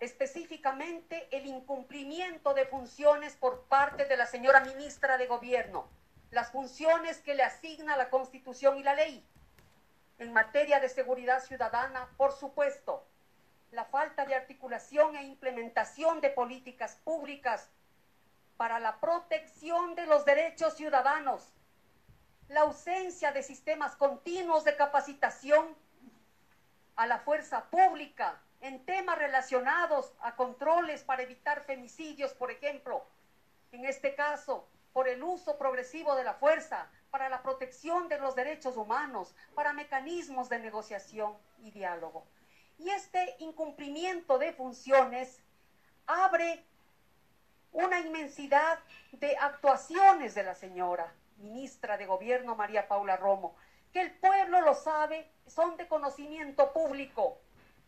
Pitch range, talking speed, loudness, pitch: 255-310 Hz, 120 wpm, -31 LUFS, 275 Hz